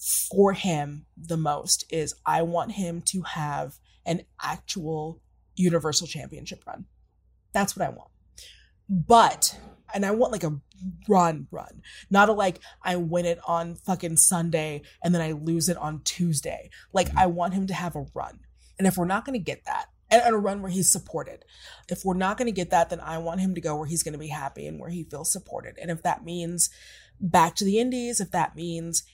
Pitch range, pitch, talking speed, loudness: 165-195 Hz, 175 Hz, 205 wpm, -25 LUFS